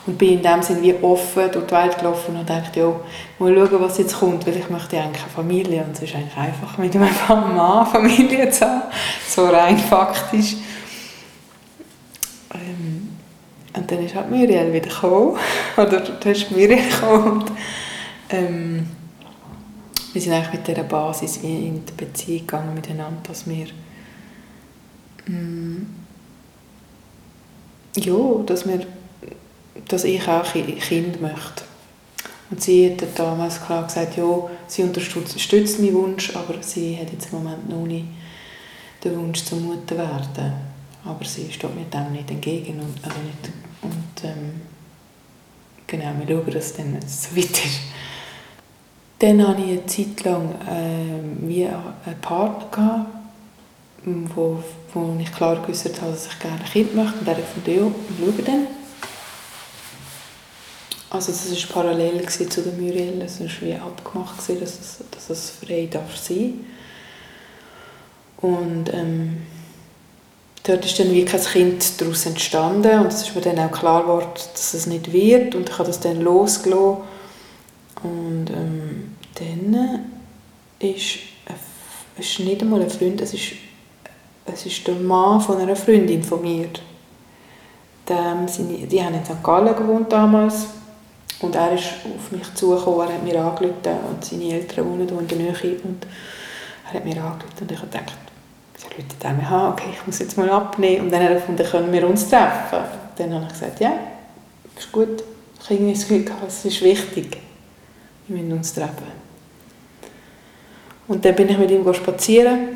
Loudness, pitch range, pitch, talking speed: -20 LUFS, 165-195 Hz, 180 Hz, 150 wpm